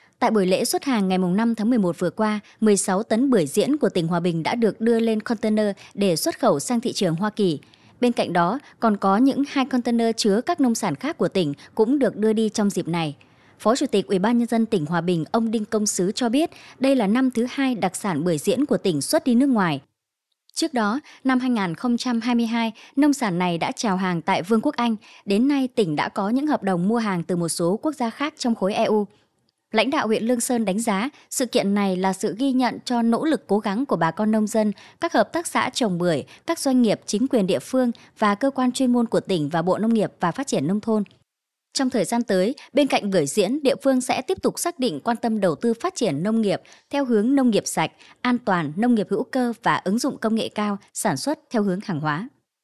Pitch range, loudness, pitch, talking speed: 195-255 Hz, -22 LUFS, 225 Hz, 245 wpm